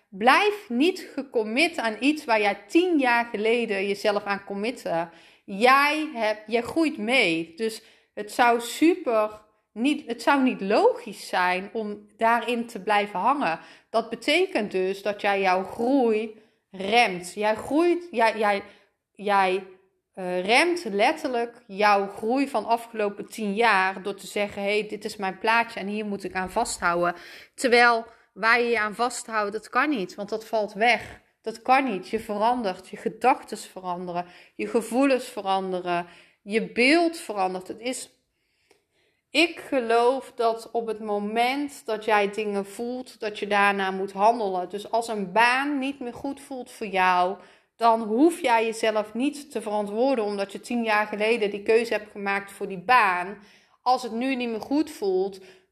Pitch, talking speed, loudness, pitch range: 220 Hz, 165 wpm, -24 LUFS, 200-245 Hz